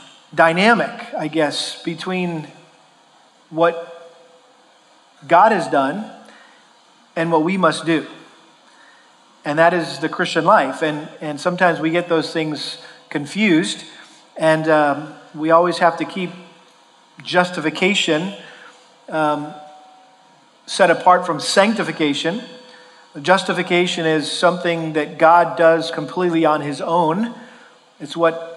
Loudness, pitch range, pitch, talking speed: -18 LUFS, 155-180 Hz, 165 Hz, 110 wpm